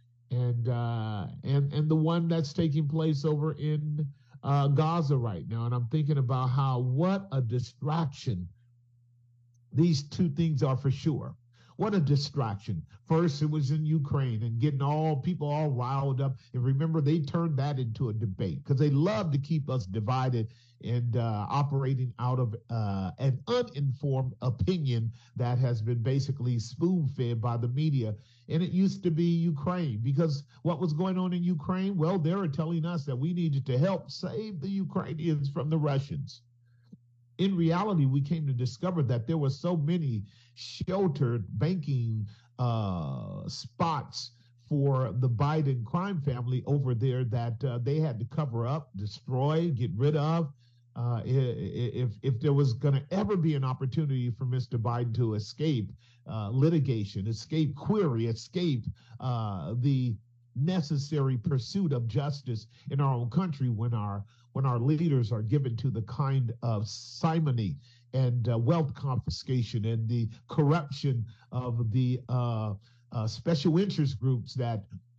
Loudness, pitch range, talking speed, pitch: -30 LUFS, 120-155 Hz, 155 wpm, 135 Hz